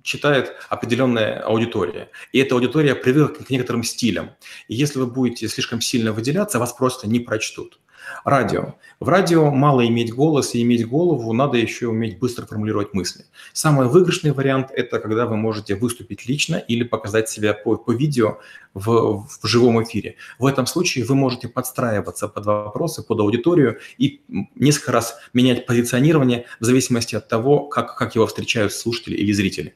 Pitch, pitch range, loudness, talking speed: 120 Hz, 110-135 Hz, -20 LUFS, 165 wpm